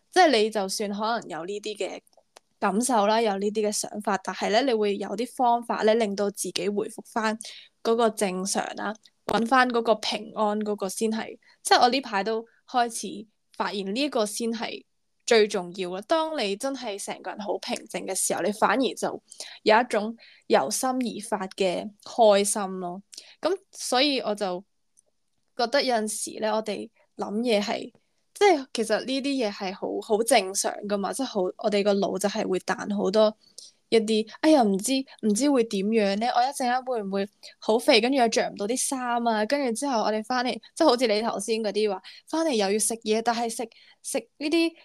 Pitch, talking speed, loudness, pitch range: 220 Hz, 270 characters per minute, -25 LUFS, 205-245 Hz